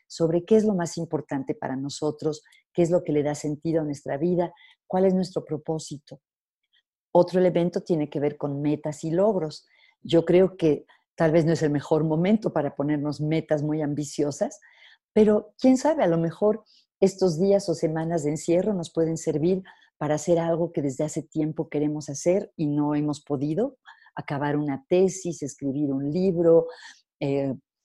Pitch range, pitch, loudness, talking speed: 150-180 Hz, 160 Hz, -25 LUFS, 175 wpm